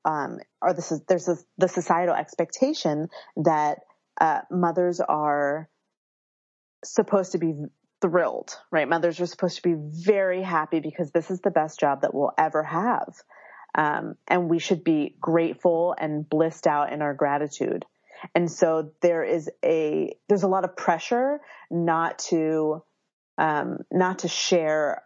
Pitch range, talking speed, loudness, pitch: 155-185 Hz, 150 wpm, -25 LUFS, 170 Hz